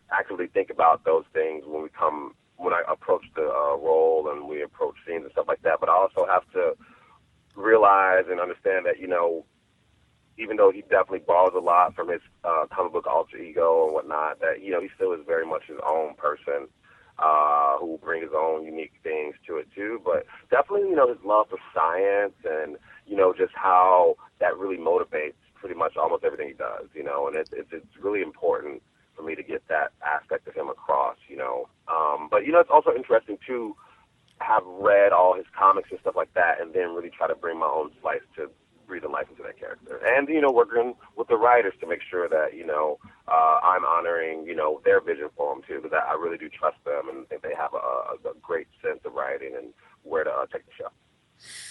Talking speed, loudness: 220 wpm, -24 LUFS